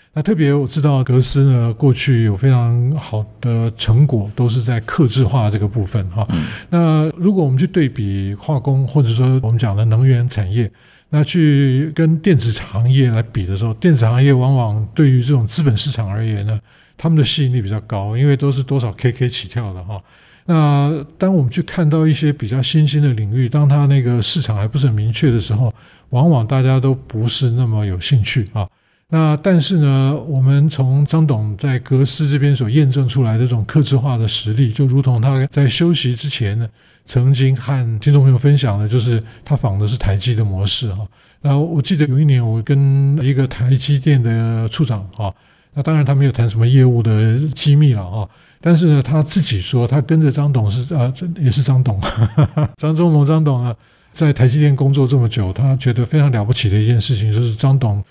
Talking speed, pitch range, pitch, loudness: 300 characters per minute, 115-145 Hz, 130 Hz, -15 LUFS